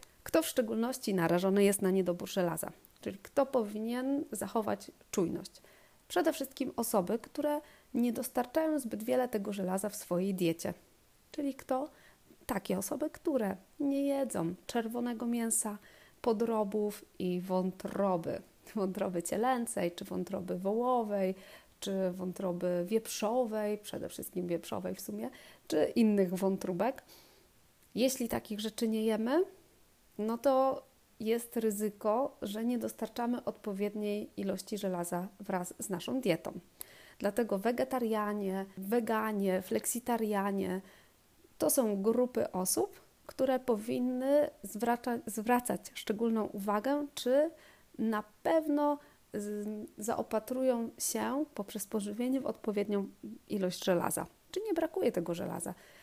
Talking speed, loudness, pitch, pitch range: 110 wpm, -34 LUFS, 220 Hz, 195-255 Hz